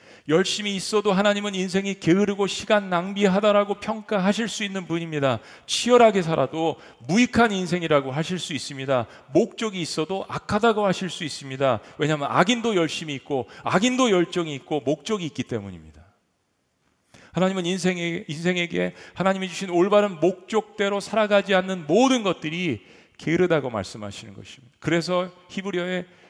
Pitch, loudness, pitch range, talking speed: 180 Hz, -23 LUFS, 150-200 Hz, 365 characters per minute